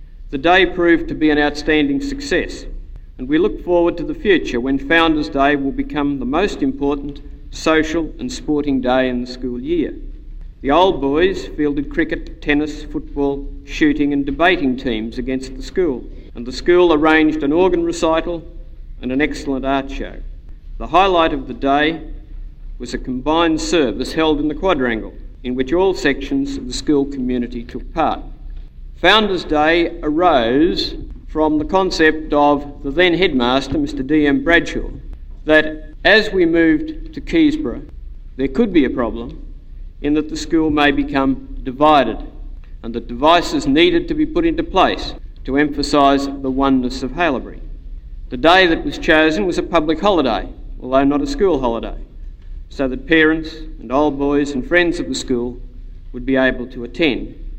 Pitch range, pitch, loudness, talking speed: 130-170 Hz, 145 Hz, -17 LUFS, 165 wpm